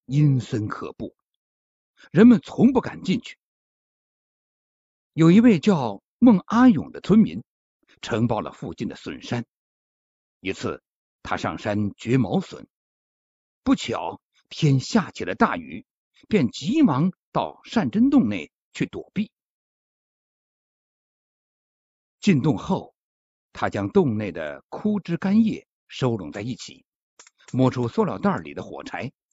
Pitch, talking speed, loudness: 185 Hz, 170 characters per minute, -22 LUFS